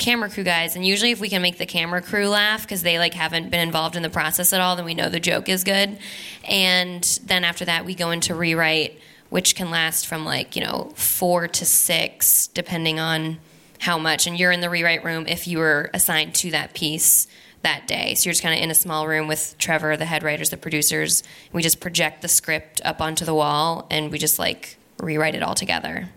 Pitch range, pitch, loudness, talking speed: 160-180 Hz, 170 Hz, -20 LUFS, 230 wpm